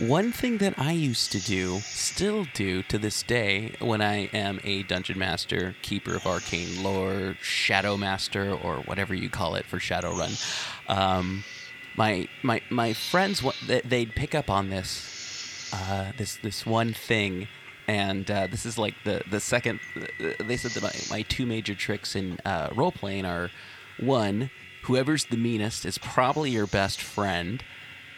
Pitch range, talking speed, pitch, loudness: 95-120 Hz, 160 wpm, 105 Hz, -28 LUFS